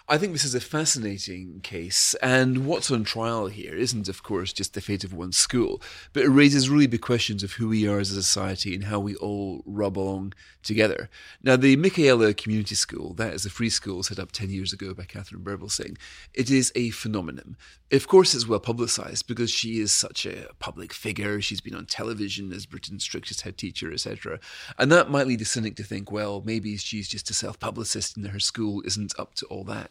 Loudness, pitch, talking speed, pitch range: -24 LUFS, 105 Hz, 215 wpm, 100-120 Hz